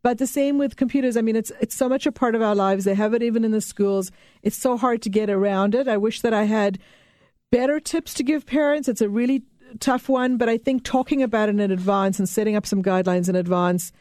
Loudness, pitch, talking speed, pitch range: -22 LUFS, 225 Hz, 255 wpm, 200-260 Hz